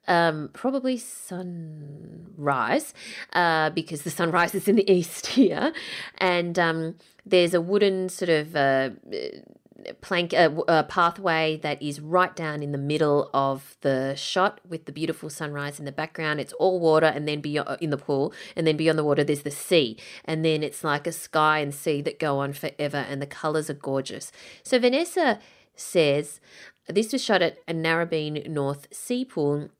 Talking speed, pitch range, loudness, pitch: 175 wpm, 145-180 Hz, -25 LUFS, 160 Hz